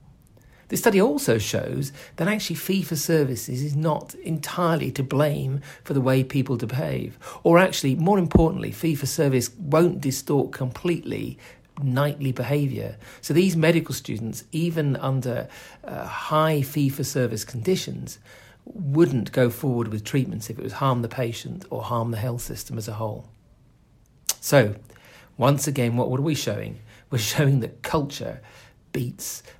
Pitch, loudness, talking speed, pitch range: 135 Hz, -24 LUFS, 150 wpm, 125-155 Hz